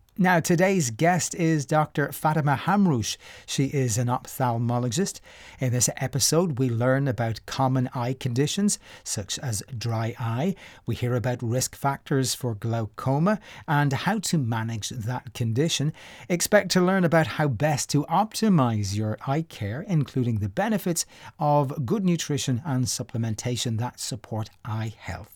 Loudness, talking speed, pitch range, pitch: -25 LUFS, 140 wpm, 120-160 Hz, 135 Hz